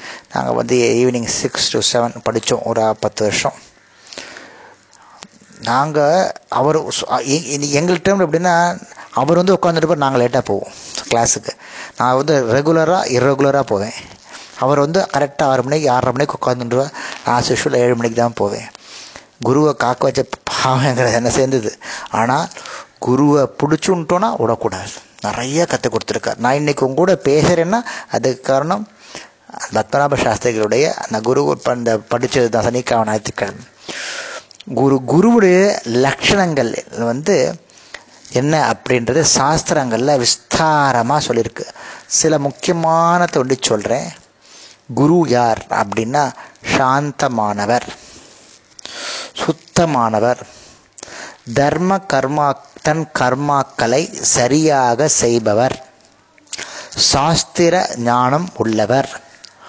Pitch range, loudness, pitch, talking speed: 120-155 Hz, -16 LUFS, 135 Hz, 95 wpm